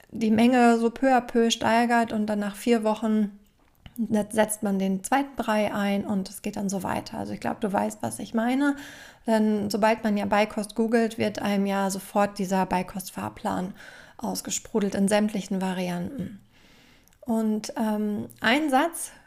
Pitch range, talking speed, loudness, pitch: 200-230 Hz, 160 wpm, -25 LUFS, 215 Hz